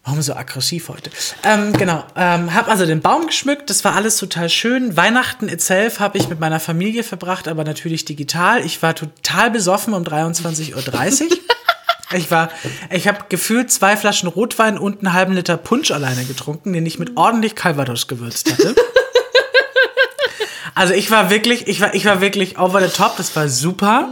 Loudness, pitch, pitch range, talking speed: -16 LUFS, 190 Hz, 165-225 Hz, 180 wpm